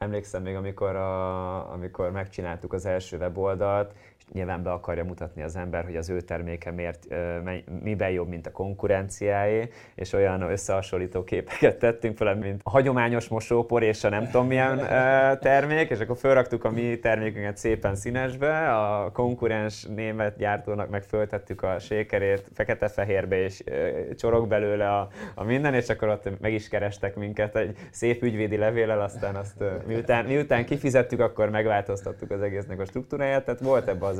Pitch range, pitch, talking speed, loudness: 95-120 Hz, 105 Hz, 155 wpm, -26 LUFS